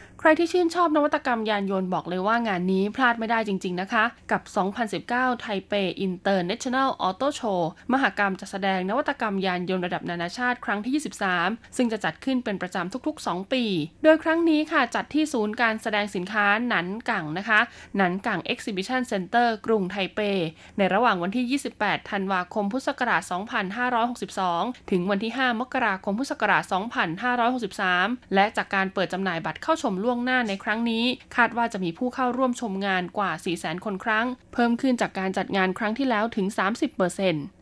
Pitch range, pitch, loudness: 190-245 Hz, 210 Hz, -25 LUFS